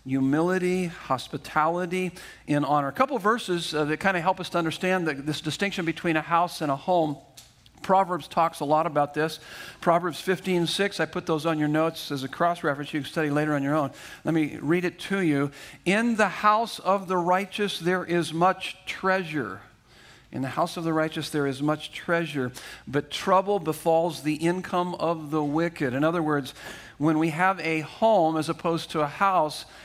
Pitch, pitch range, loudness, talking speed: 165 Hz, 150-180 Hz, -26 LUFS, 195 wpm